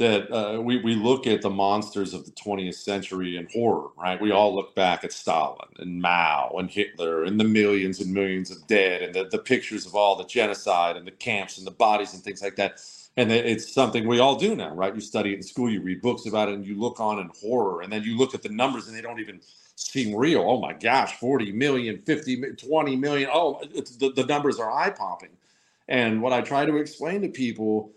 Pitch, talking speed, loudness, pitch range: 110 Hz, 240 wpm, -25 LUFS, 100-125 Hz